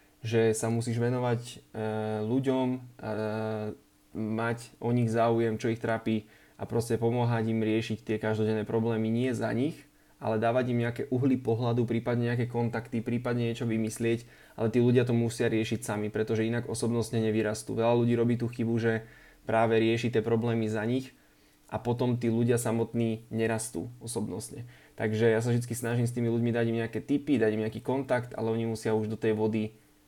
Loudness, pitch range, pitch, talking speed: -29 LUFS, 110-120 Hz, 115 Hz, 175 wpm